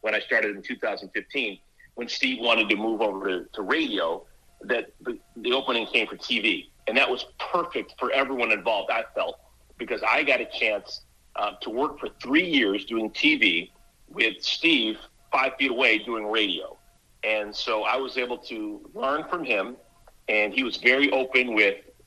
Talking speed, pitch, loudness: 170 wpm, 145 Hz, -24 LUFS